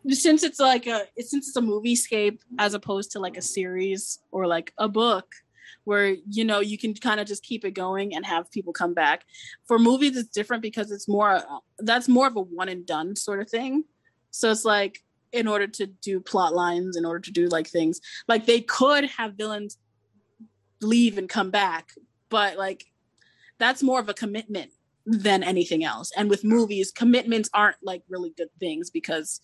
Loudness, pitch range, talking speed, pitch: -24 LUFS, 185-230 Hz, 195 wpm, 205 Hz